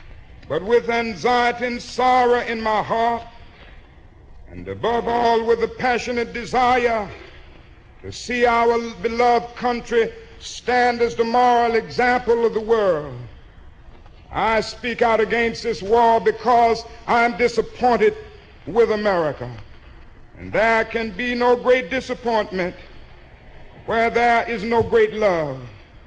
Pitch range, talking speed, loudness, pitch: 215-240 Hz, 120 wpm, -19 LUFS, 230 Hz